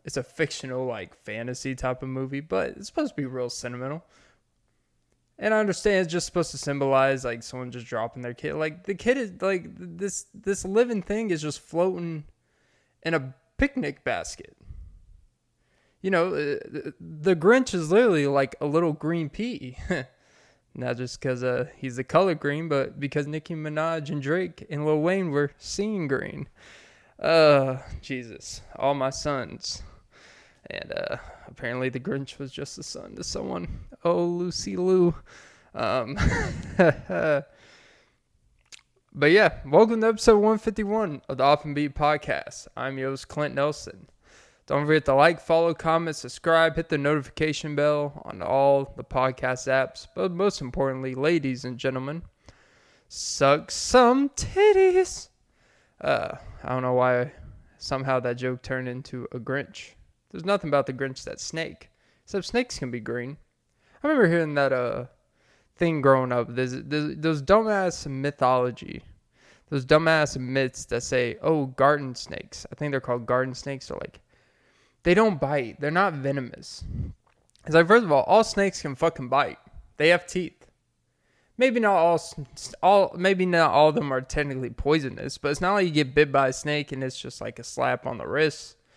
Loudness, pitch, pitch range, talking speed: -25 LUFS, 150 Hz, 130-175 Hz, 160 wpm